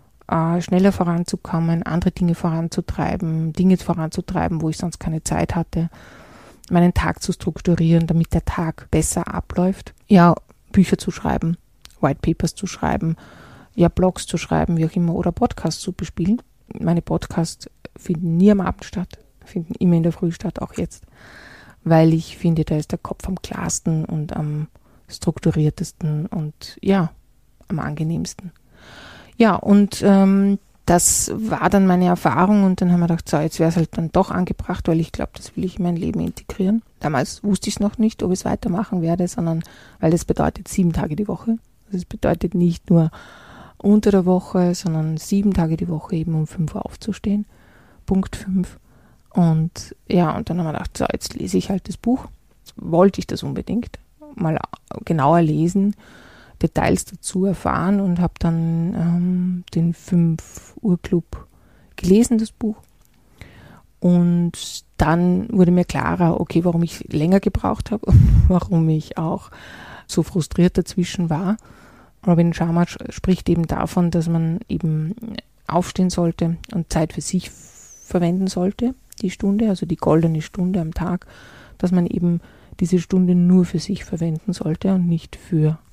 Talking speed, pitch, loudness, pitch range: 160 wpm, 175 Hz, -20 LUFS, 165-190 Hz